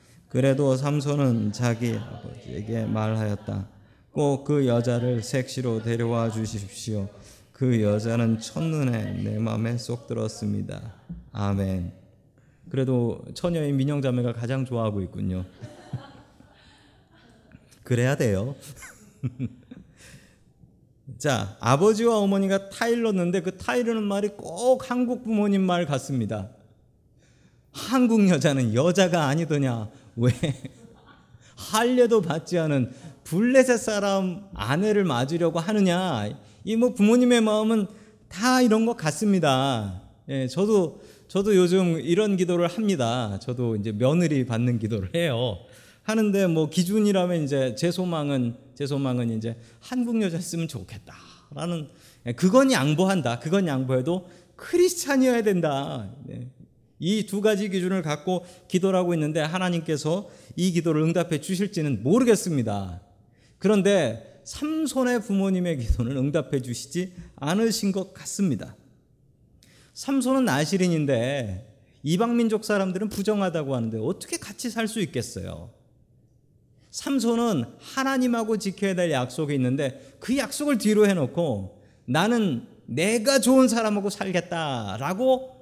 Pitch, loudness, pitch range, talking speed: 155 Hz, -24 LUFS, 120-200 Hz, 270 characters per minute